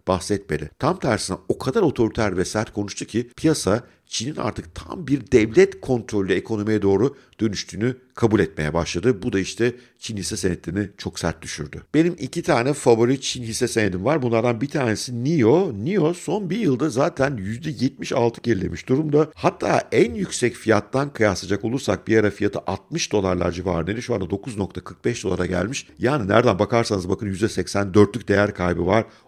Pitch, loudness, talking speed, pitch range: 110 Hz, -22 LUFS, 160 wpm, 95-125 Hz